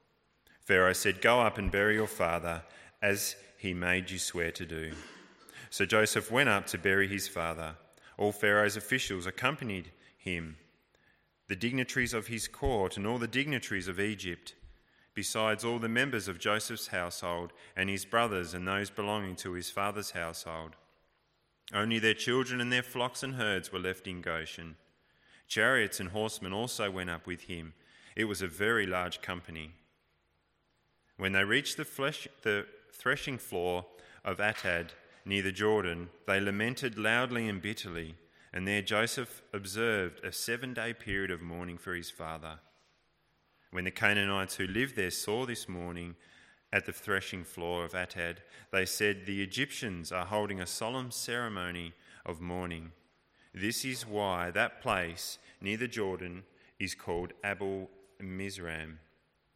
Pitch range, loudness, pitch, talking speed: 85-110 Hz, -33 LUFS, 95 Hz, 150 wpm